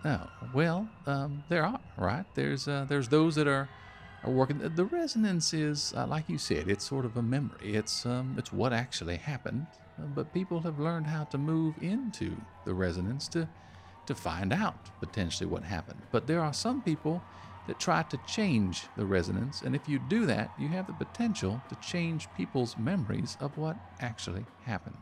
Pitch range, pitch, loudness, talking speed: 105-160 Hz, 135 Hz, -33 LUFS, 185 wpm